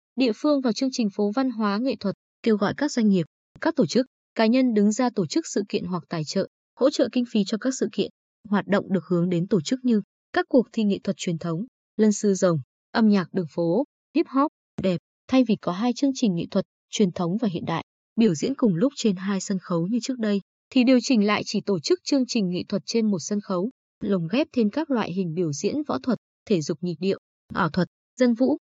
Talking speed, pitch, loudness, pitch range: 250 wpm, 210 Hz, -24 LUFS, 190-250 Hz